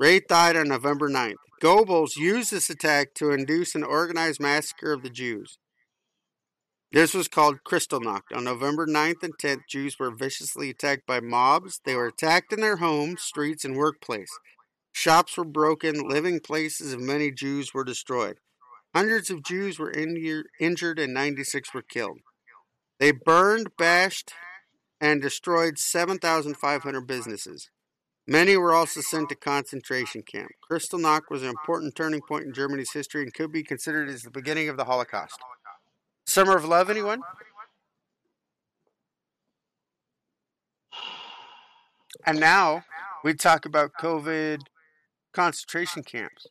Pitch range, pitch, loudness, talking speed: 140-170 Hz, 155 Hz, -24 LUFS, 135 wpm